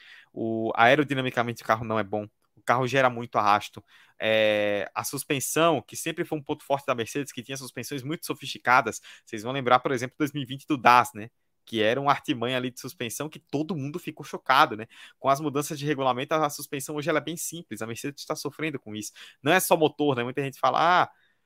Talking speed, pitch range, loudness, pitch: 215 wpm, 120-150 Hz, -26 LUFS, 135 Hz